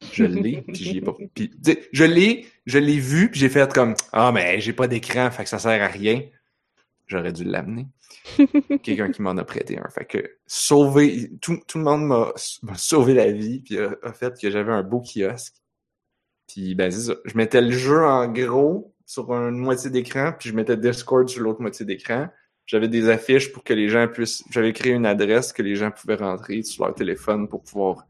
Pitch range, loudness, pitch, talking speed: 110-145 Hz, -21 LUFS, 125 Hz, 215 wpm